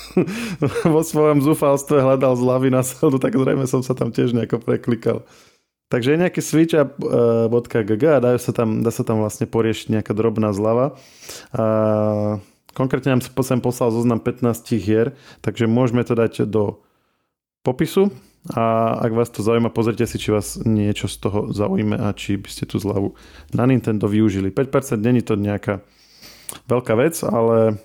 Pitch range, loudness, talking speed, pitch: 110-135 Hz, -19 LUFS, 160 wpm, 120 Hz